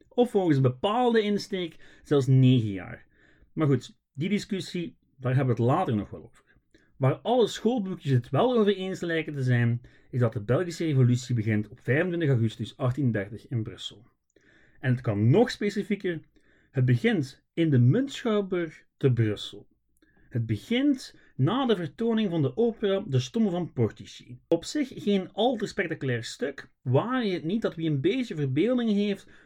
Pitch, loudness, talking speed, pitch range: 155 Hz, -27 LUFS, 170 wpm, 125-200 Hz